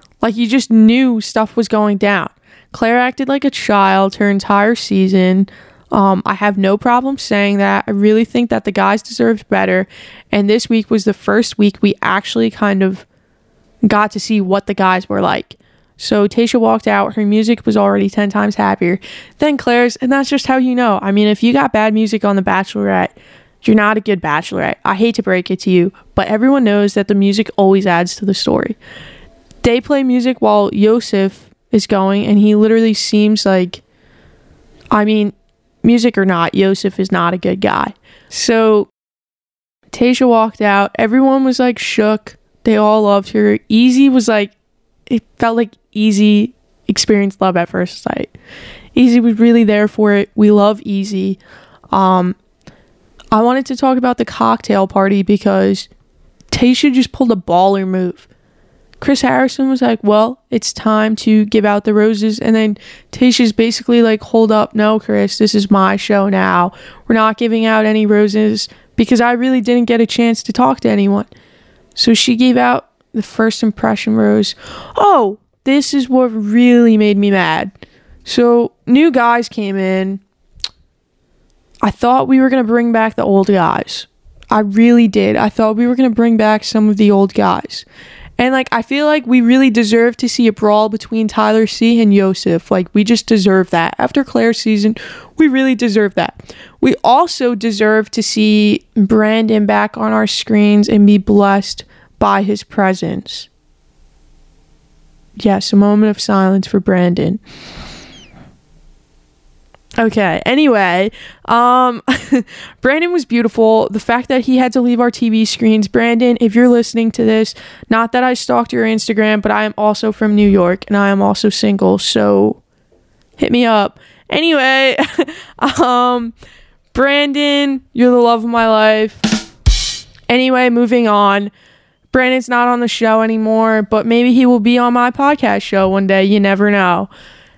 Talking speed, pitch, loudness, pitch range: 170 wpm, 220 Hz, -12 LUFS, 200-240 Hz